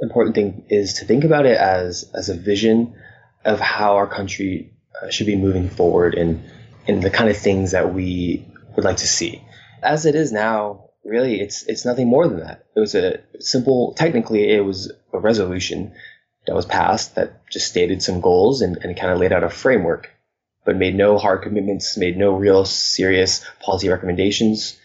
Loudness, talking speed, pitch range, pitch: -18 LUFS, 190 wpm, 95-110 Hz, 100 Hz